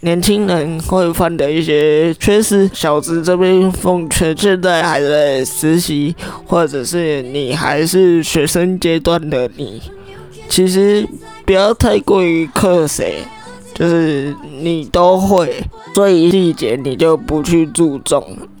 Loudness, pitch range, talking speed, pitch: -13 LUFS, 150-180 Hz, 185 characters per minute, 165 Hz